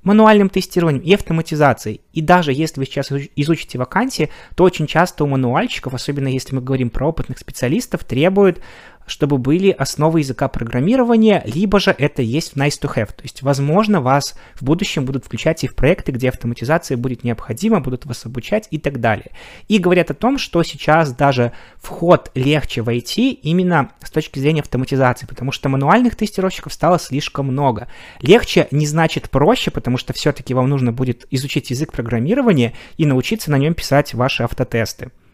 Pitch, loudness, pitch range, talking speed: 145 Hz, -17 LUFS, 130-170 Hz, 170 wpm